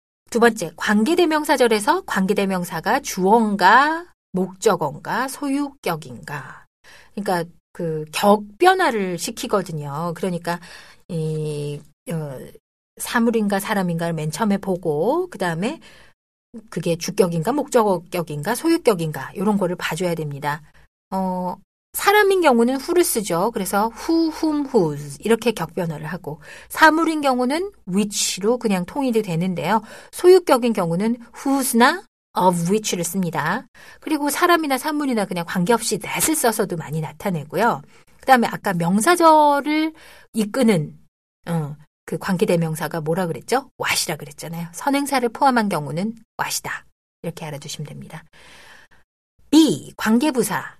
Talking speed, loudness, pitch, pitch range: 325 characters per minute, -20 LUFS, 205 Hz, 170-265 Hz